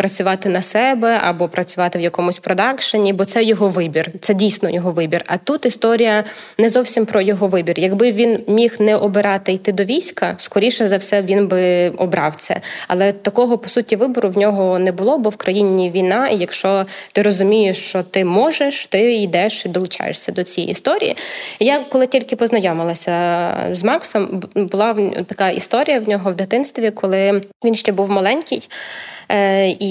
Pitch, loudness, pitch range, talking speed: 200 Hz, -16 LUFS, 185-225 Hz, 170 wpm